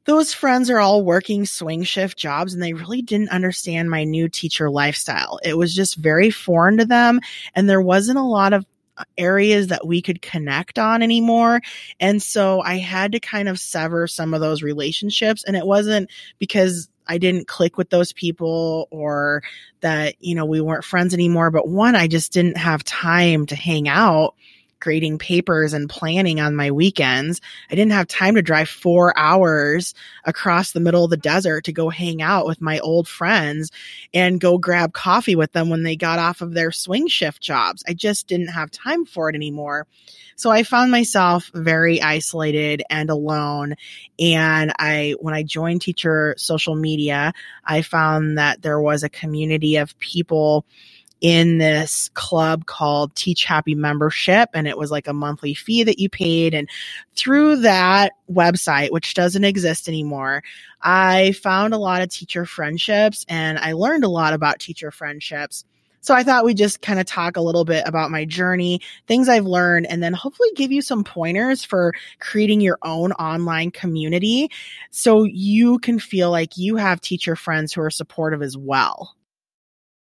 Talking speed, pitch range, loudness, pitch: 180 wpm, 155-195 Hz, -18 LUFS, 170 Hz